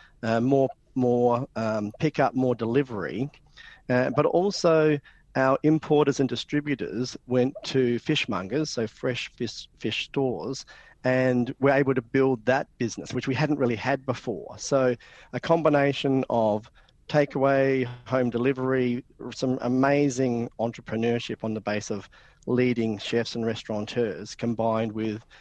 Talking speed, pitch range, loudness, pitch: 130 wpm, 115-135 Hz, -26 LUFS, 125 Hz